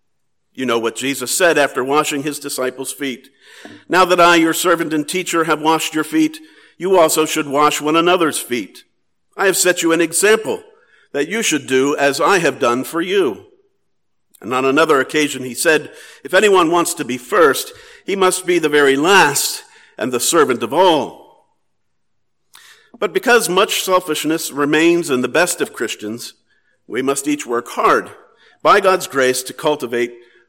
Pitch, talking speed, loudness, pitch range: 155 Hz, 170 wpm, -15 LUFS, 140-185 Hz